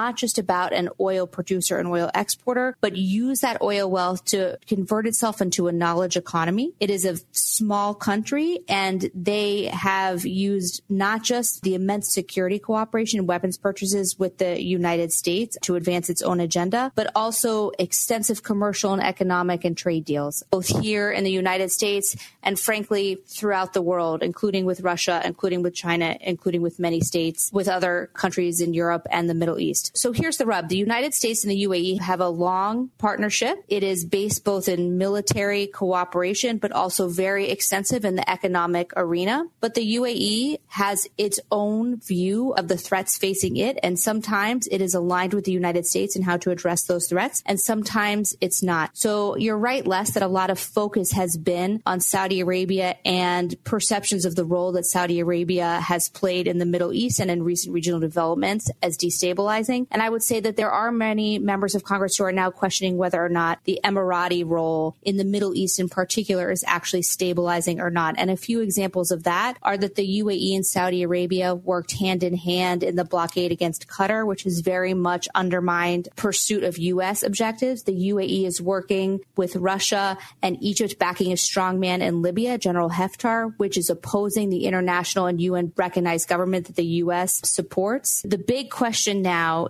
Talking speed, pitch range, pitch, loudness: 185 wpm, 180-205 Hz, 190 Hz, -23 LUFS